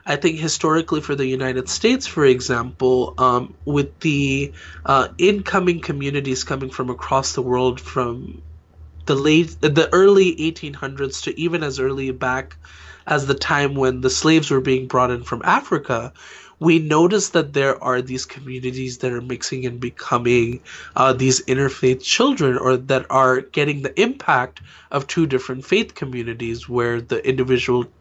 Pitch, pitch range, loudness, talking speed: 130 Hz, 125-150 Hz, -19 LUFS, 155 wpm